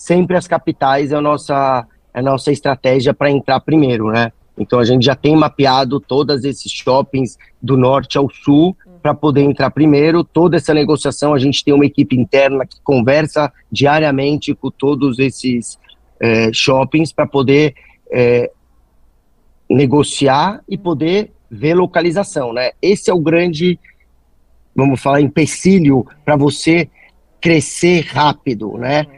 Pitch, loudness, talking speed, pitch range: 140 Hz, -14 LUFS, 140 wpm, 130-155 Hz